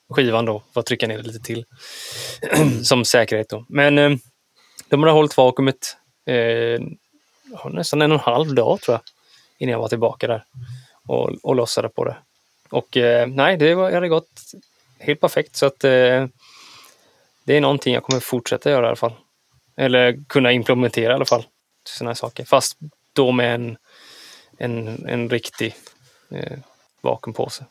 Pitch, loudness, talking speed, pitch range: 130 Hz, -19 LUFS, 165 wpm, 120-145 Hz